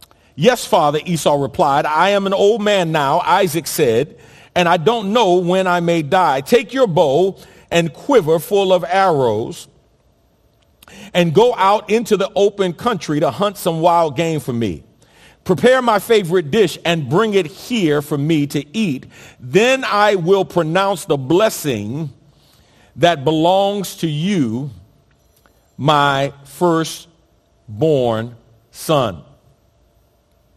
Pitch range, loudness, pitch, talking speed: 145-195 Hz, -16 LUFS, 170 Hz, 130 wpm